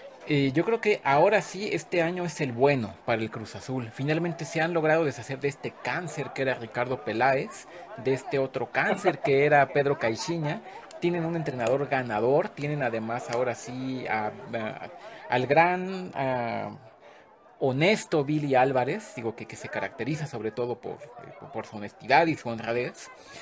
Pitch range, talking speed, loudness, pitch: 120-160 Hz, 170 wpm, -27 LUFS, 135 Hz